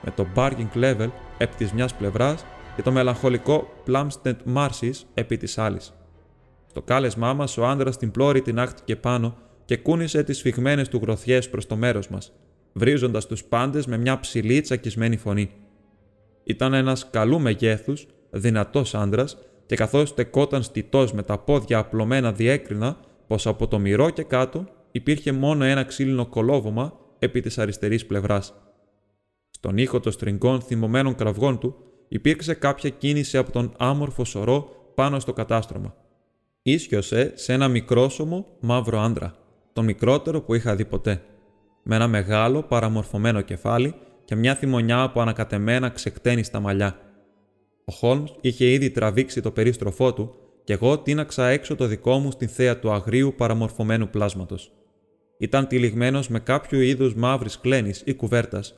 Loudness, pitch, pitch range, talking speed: -23 LUFS, 120 Hz, 110-130 Hz, 150 wpm